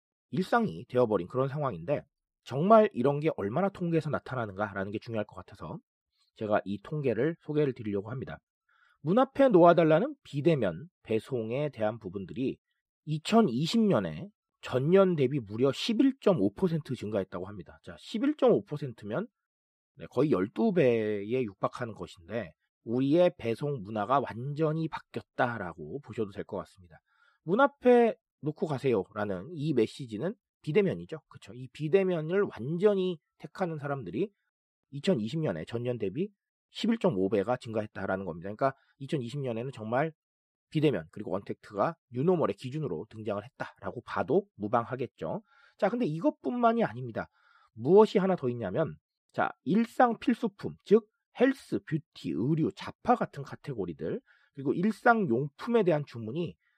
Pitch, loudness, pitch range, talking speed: 150 Hz, -30 LUFS, 115-195 Hz, 300 characters per minute